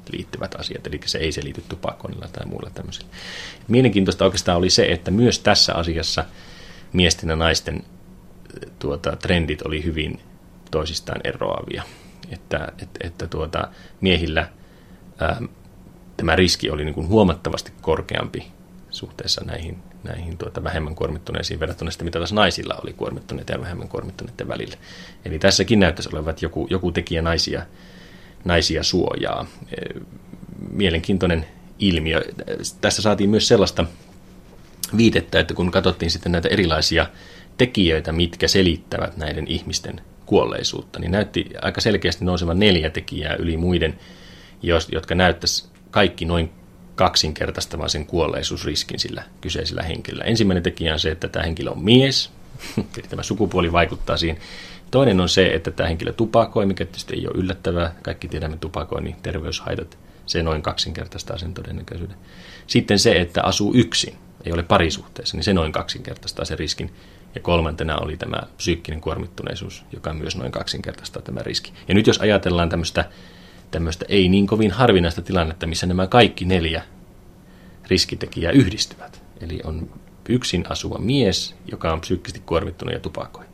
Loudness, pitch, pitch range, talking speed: -21 LUFS, 90 Hz, 80-95 Hz, 140 wpm